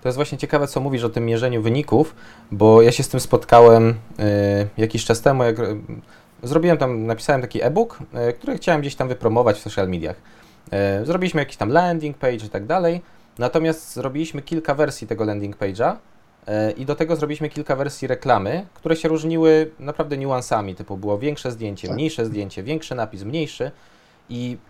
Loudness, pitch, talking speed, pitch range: -20 LUFS, 125 Hz, 170 wpm, 115-150 Hz